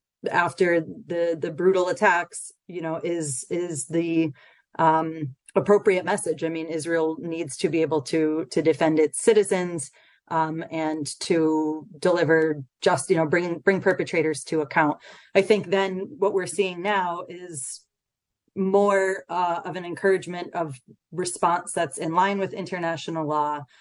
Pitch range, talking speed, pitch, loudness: 160-185 Hz, 145 wpm, 170 Hz, -24 LUFS